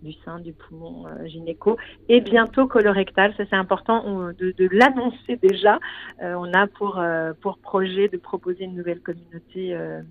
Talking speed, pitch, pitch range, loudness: 170 wpm, 190 Hz, 175-210 Hz, -21 LUFS